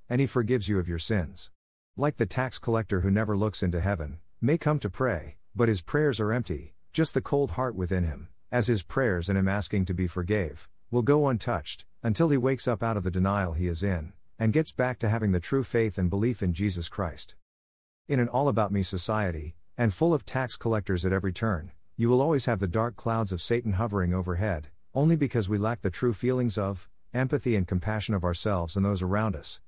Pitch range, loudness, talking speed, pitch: 90-120 Hz, -28 LUFS, 220 wpm, 105 Hz